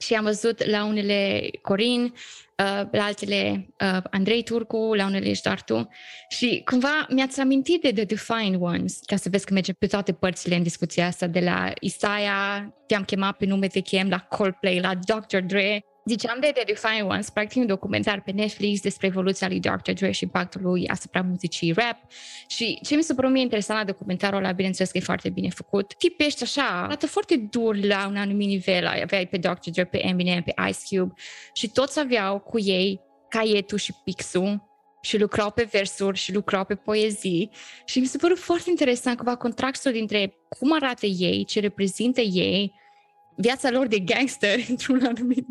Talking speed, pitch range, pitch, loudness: 185 wpm, 190-235 Hz, 205 Hz, -24 LUFS